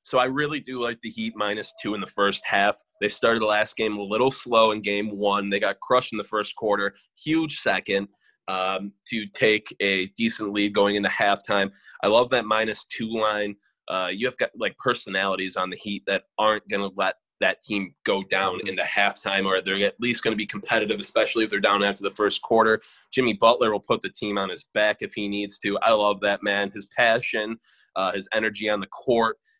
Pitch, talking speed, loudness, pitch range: 105 Hz, 220 wpm, -24 LUFS, 100-110 Hz